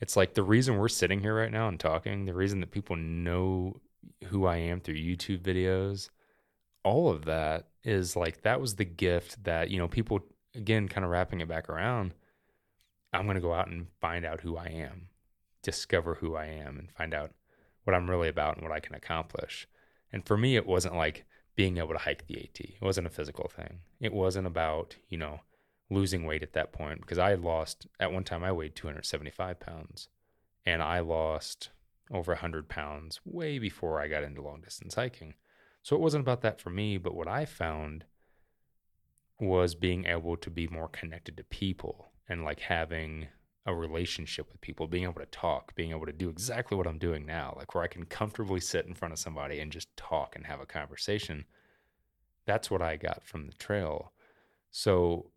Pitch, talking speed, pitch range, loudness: 90 Hz, 200 wpm, 80-95 Hz, -33 LUFS